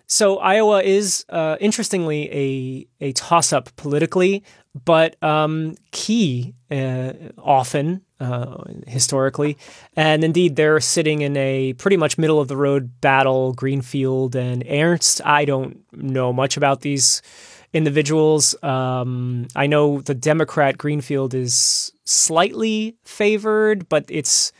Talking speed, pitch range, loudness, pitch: 115 wpm, 135-165 Hz, -18 LUFS, 145 Hz